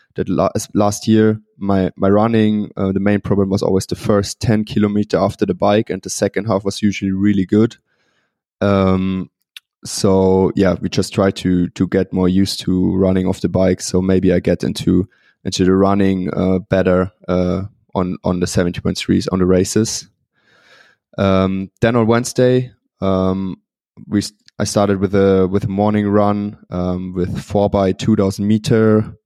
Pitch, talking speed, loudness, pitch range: 95 Hz, 170 wpm, -16 LUFS, 95-105 Hz